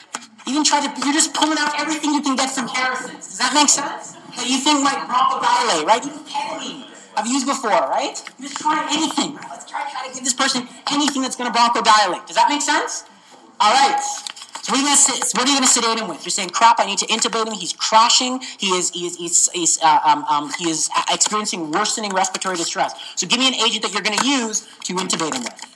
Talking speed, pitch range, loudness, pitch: 240 wpm, 215-290 Hz, -18 LUFS, 255 Hz